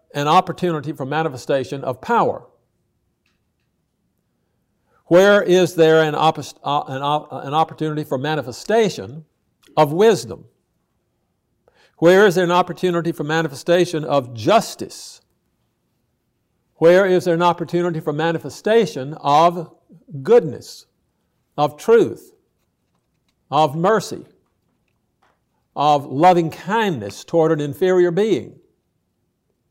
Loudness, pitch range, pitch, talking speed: -18 LUFS, 145-180 Hz, 160 Hz, 95 wpm